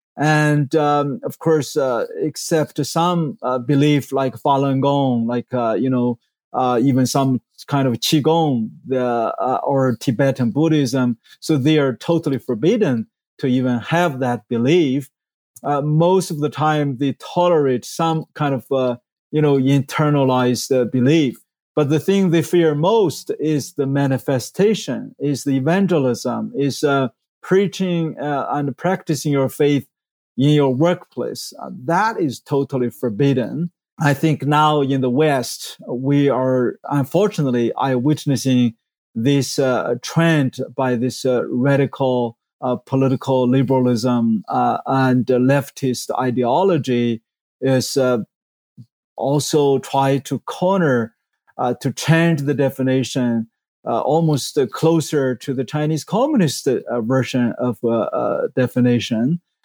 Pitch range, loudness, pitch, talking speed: 125-150 Hz, -18 LUFS, 135 Hz, 135 wpm